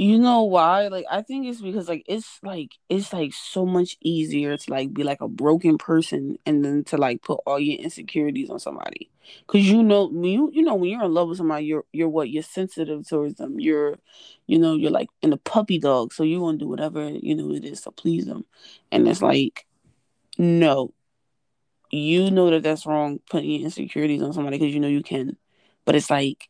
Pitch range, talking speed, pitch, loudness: 150-215 Hz, 220 wpm, 165 Hz, -22 LUFS